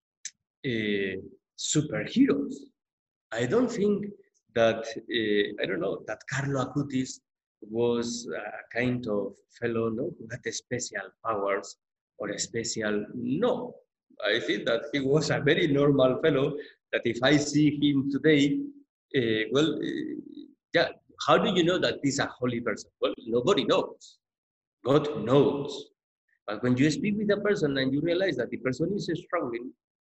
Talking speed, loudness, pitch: 150 wpm, -28 LUFS, 145 Hz